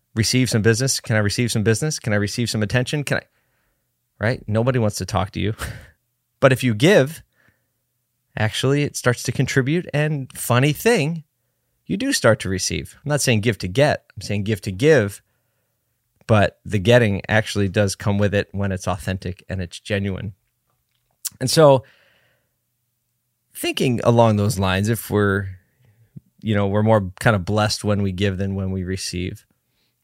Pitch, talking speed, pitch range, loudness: 115 Hz, 170 wpm, 100-125 Hz, -20 LUFS